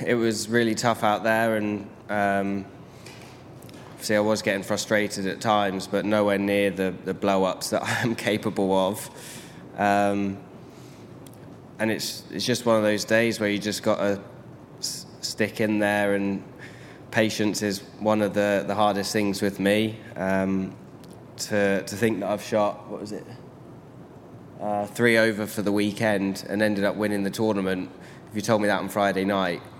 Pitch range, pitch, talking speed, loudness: 100-110 Hz, 105 Hz, 170 wpm, -25 LUFS